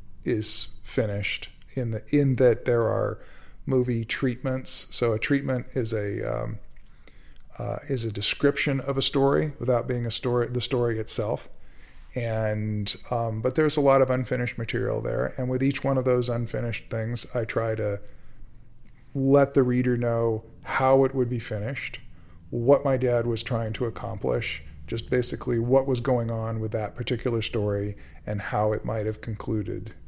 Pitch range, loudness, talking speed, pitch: 110-130 Hz, -26 LUFS, 165 wpm, 120 Hz